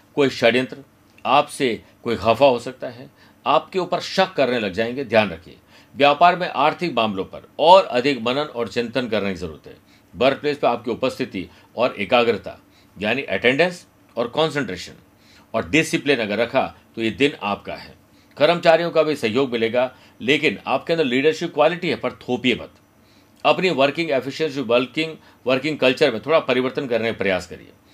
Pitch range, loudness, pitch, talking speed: 110-150 Hz, -20 LUFS, 130 Hz, 165 wpm